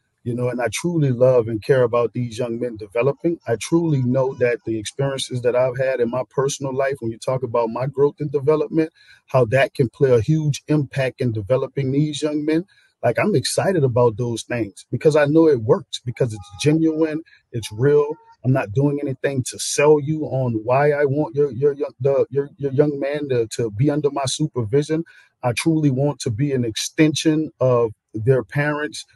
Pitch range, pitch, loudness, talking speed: 125-150 Hz, 135 Hz, -20 LUFS, 200 wpm